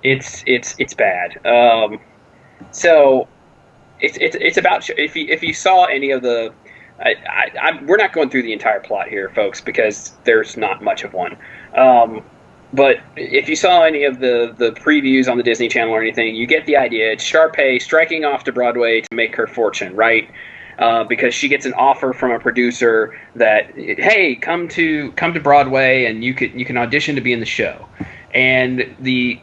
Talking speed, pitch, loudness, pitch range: 195 wpm, 130 Hz, -15 LUFS, 115-155 Hz